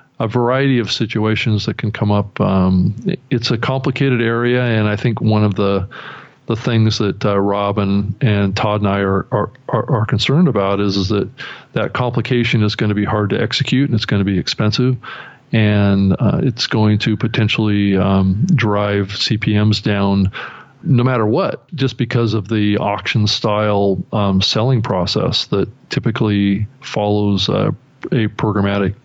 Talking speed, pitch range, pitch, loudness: 165 wpm, 100-120 Hz, 105 Hz, -16 LUFS